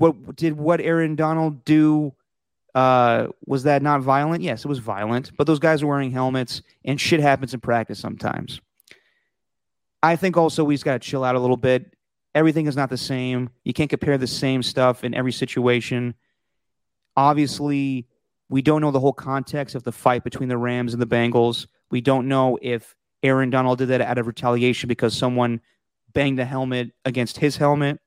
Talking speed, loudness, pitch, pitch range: 185 wpm, -21 LUFS, 130 Hz, 125-145 Hz